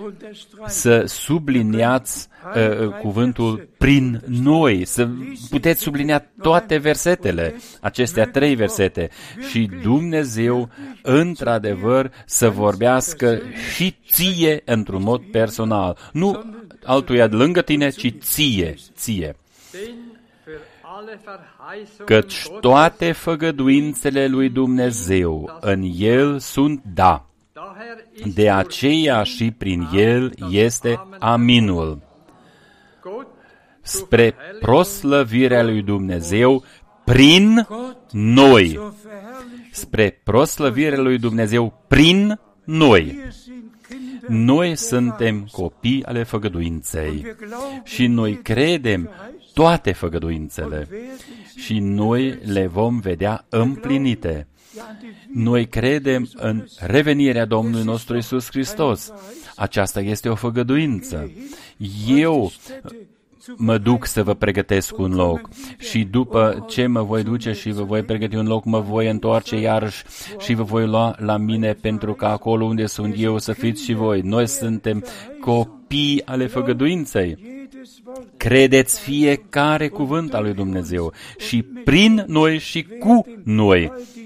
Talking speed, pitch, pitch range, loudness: 105 wpm, 120 Hz, 110-155 Hz, -18 LUFS